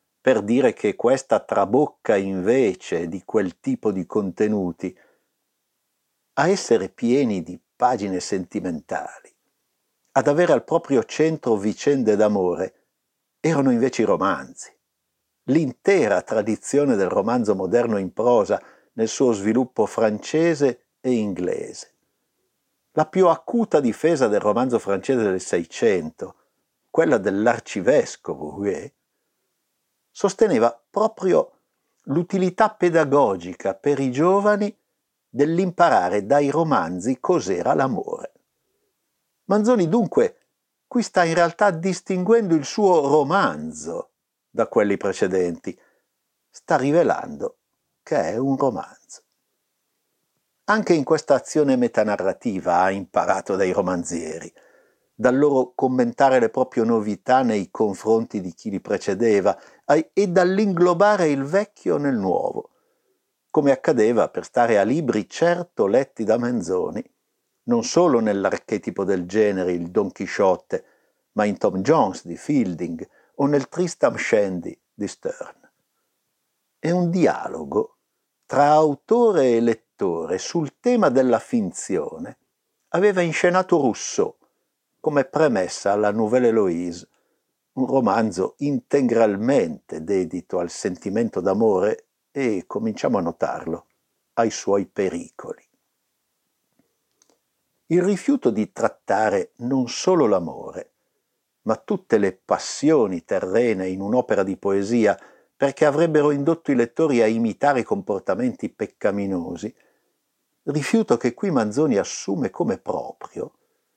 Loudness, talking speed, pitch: -21 LUFS, 110 wpm, 150 Hz